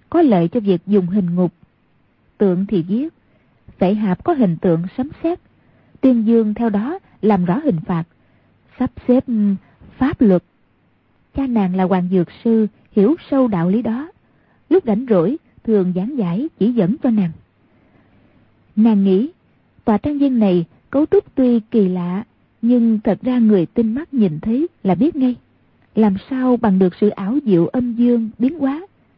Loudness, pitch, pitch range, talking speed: -17 LUFS, 215 Hz, 185-250 Hz, 170 wpm